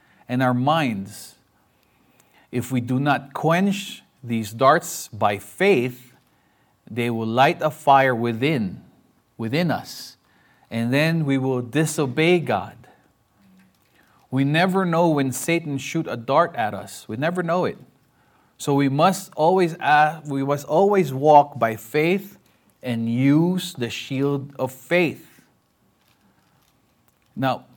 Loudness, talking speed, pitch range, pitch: -21 LUFS, 125 wpm, 120-165 Hz, 140 Hz